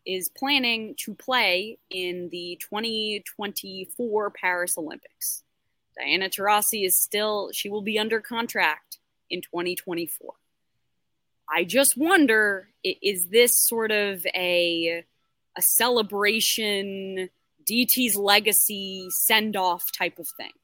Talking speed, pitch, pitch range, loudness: 105 wpm, 205 Hz, 180-220 Hz, -23 LUFS